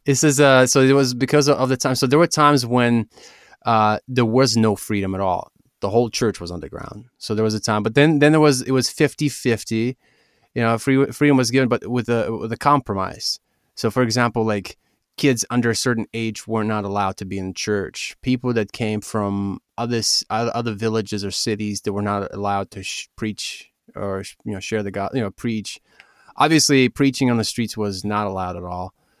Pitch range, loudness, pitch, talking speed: 105-130 Hz, -20 LUFS, 115 Hz, 215 wpm